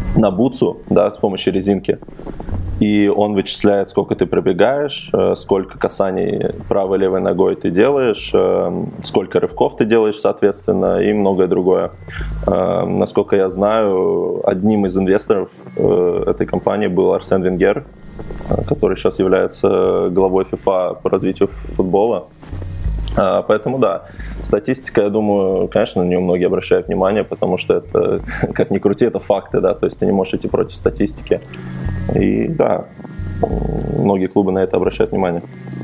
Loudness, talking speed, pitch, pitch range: -17 LUFS, 135 wpm, 95 Hz, 95-110 Hz